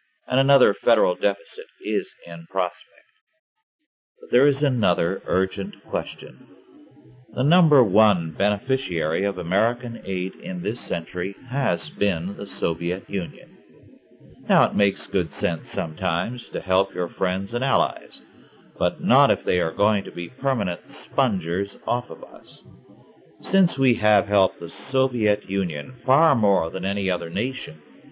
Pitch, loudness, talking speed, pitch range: 105 Hz, -23 LUFS, 140 wpm, 95-135 Hz